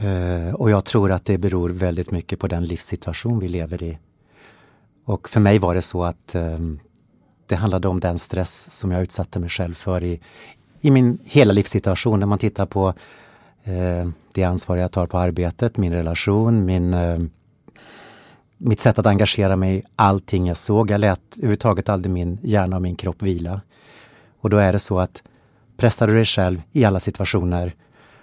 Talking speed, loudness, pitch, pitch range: 185 wpm, -20 LUFS, 95 Hz, 90-105 Hz